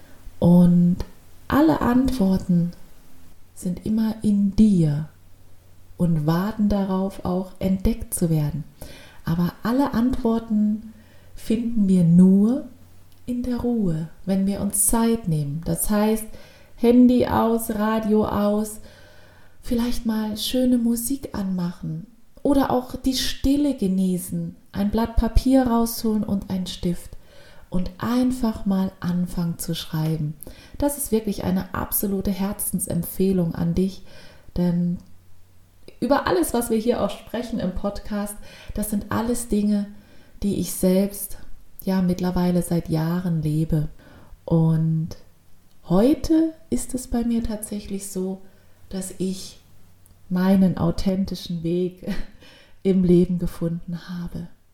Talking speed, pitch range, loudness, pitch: 115 wpm, 170-220 Hz, -22 LUFS, 190 Hz